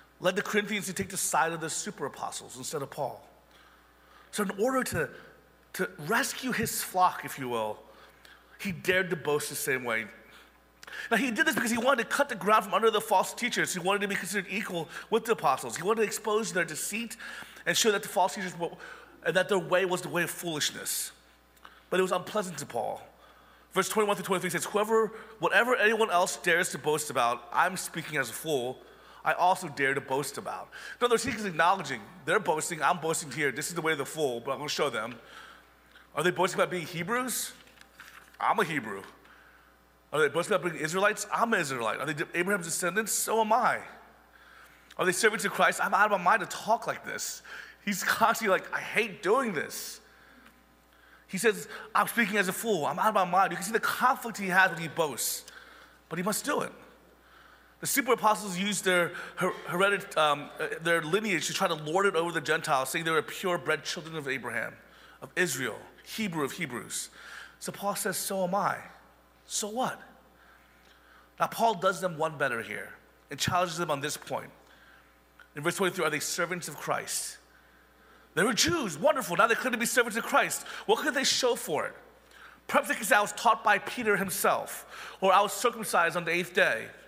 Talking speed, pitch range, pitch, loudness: 205 wpm, 160-215 Hz, 185 Hz, -29 LUFS